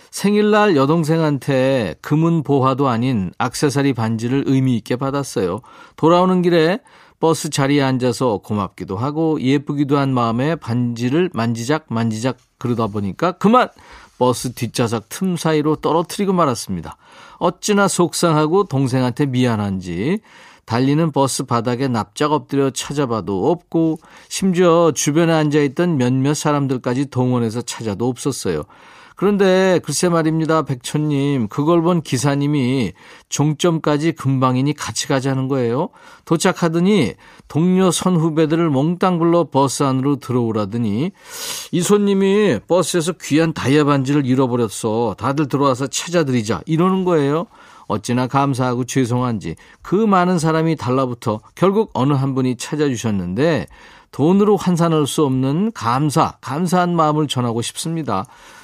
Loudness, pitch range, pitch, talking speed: -18 LUFS, 125-170 Hz, 145 Hz, 320 characters per minute